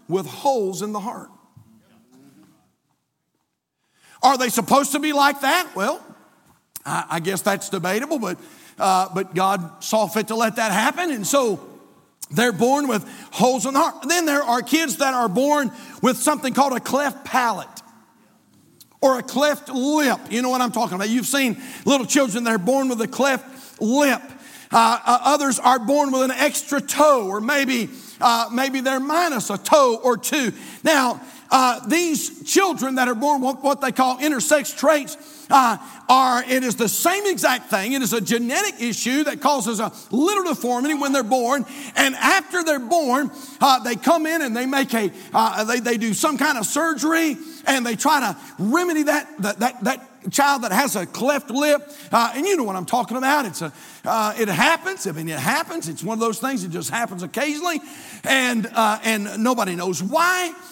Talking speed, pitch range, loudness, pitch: 185 wpm, 230-290 Hz, -20 LUFS, 260 Hz